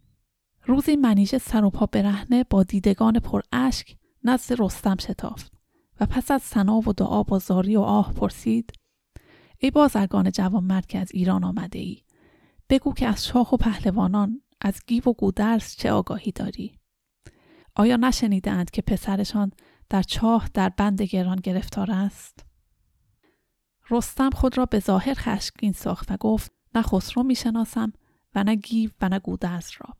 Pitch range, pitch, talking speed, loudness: 195-240 Hz, 210 Hz, 150 wpm, -23 LUFS